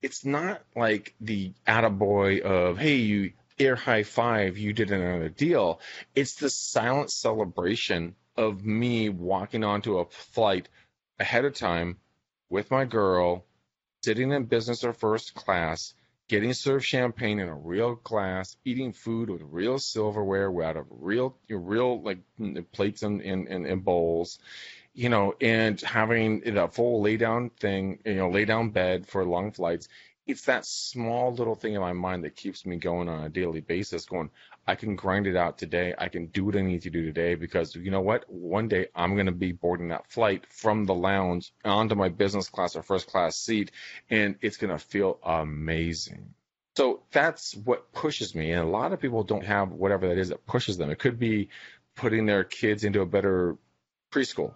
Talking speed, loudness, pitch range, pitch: 185 wpm, -28 LUFS, 90-115 Hz, 100 Hz